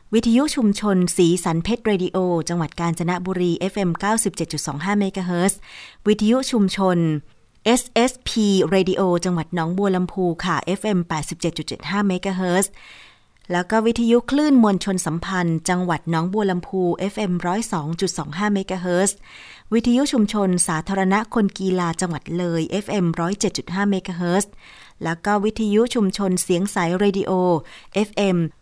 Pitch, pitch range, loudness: 185 Hz, 175-205 Hz, -21 LUFS